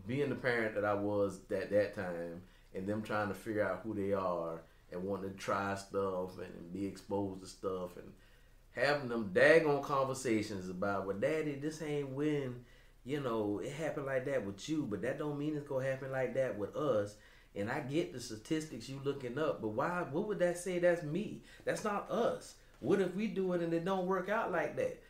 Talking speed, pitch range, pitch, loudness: 215 wpm, 100-150 Hz, 125 Hz, -36 LUFS